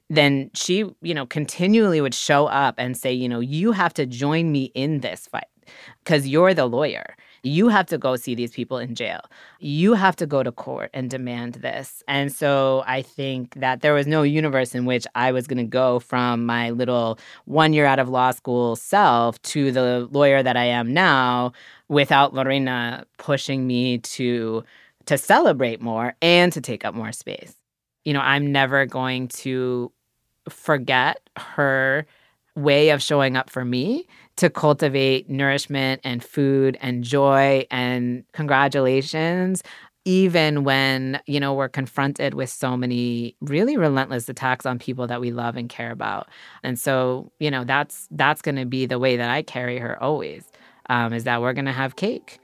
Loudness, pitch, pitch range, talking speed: -21 LUFS, 135 Hz, 125-145 Hz, 175 wpm